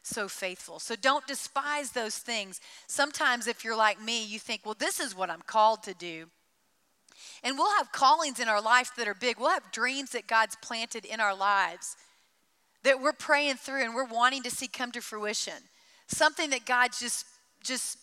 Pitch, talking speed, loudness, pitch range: 240 Hz, 195 wpm, -29 LUFS, 215-265 Hz